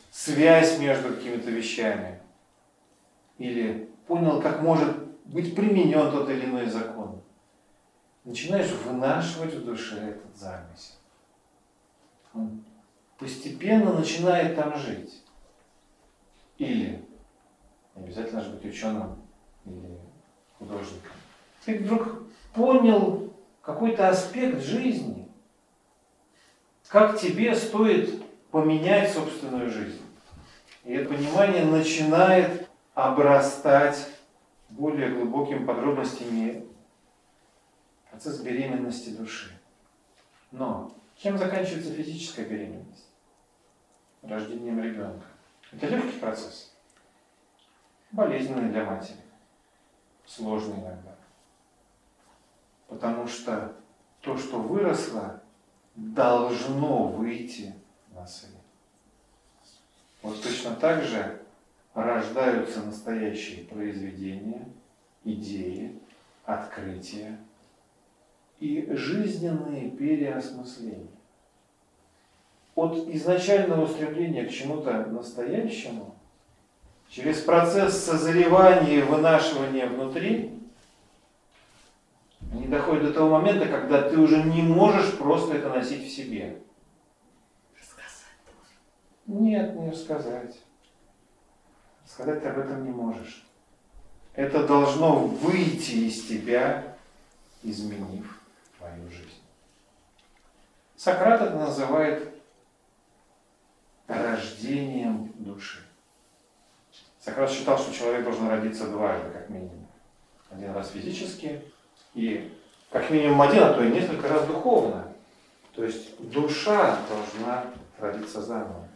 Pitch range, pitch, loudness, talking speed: 110-165 Hz, 135 Hz, -25 LUFS, 85 wpm